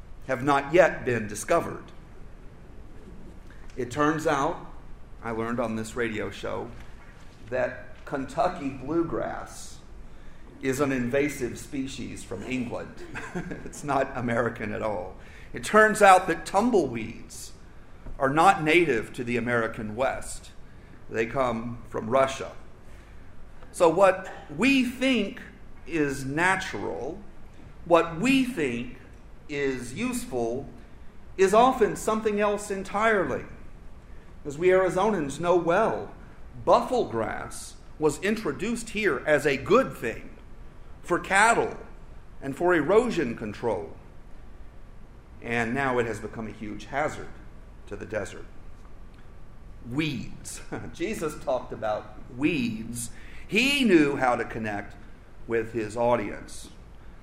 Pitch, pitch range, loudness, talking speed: 135 Hz, 115-180 Hz, -26 LUFS, 110 wpm